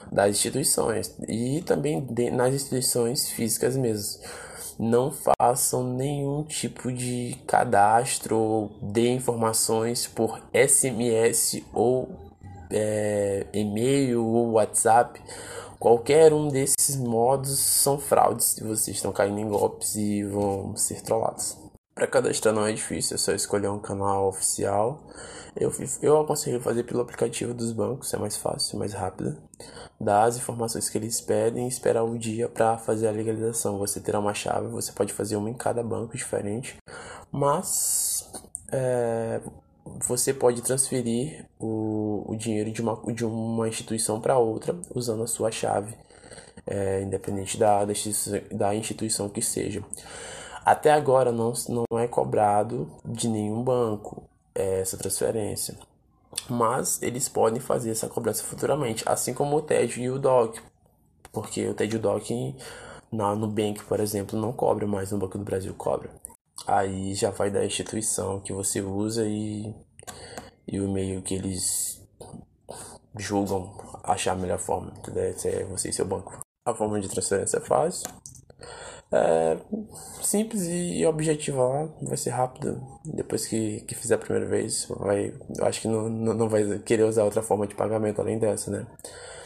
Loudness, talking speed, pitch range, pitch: -26 LUFS, 145 wpm, 105-125 Hz, 110 Hz